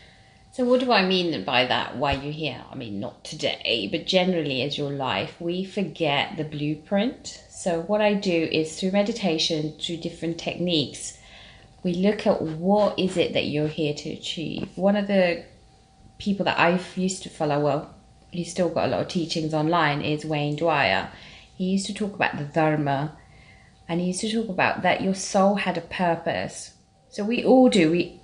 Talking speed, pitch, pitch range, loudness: 190 wpm, 170 Hz, 155-190 Hz, -24 LUFS